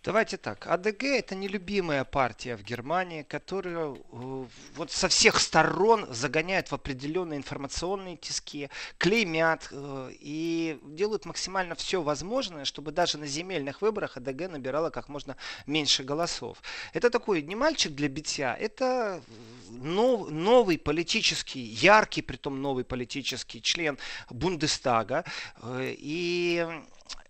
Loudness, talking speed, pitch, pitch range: -28 LUFS, 110 wpm, 155 Hz, 140-185 Hz